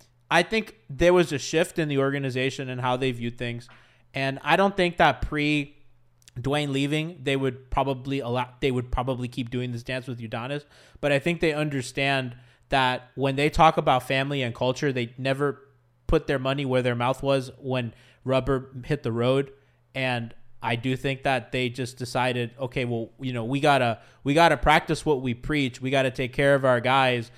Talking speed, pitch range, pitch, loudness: 195 wpm, 125-140 Hz, 130 Hz, -25 LUFS